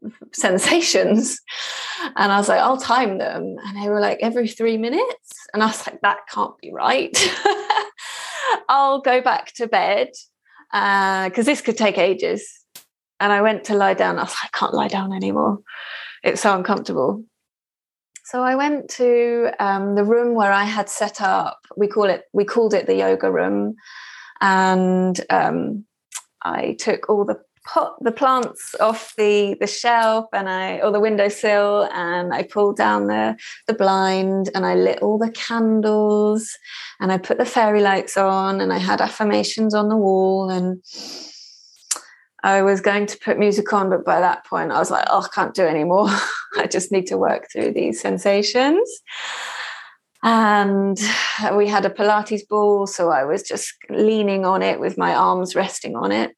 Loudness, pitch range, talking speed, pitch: -19 LUFS, 195-230 Hz, 175 wpm, 210 Hz